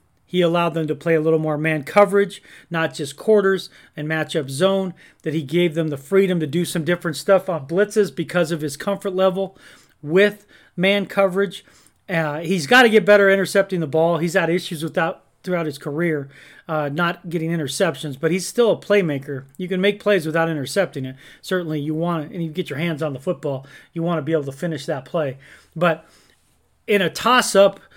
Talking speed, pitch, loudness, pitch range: 200 wpm, 170 Hz, -20 LUFS, 155-195 Hz